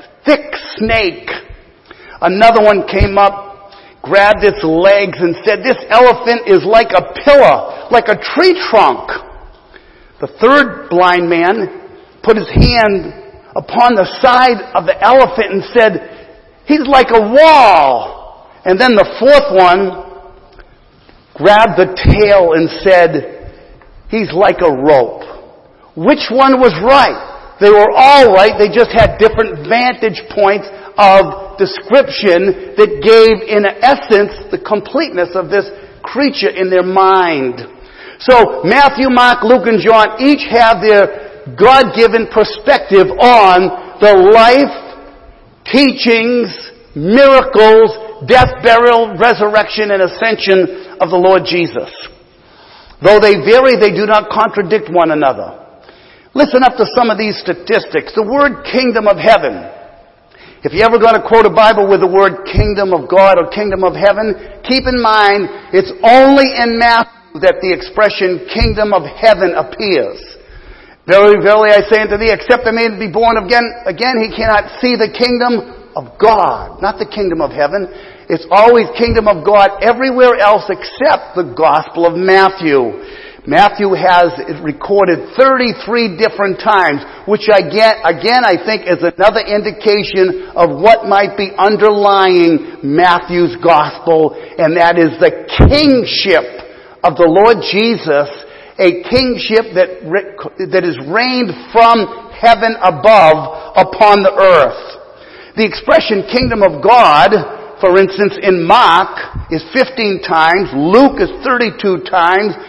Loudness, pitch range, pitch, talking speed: -9 LUFS, 190-245 Hz, 215 Hz, 135 wpm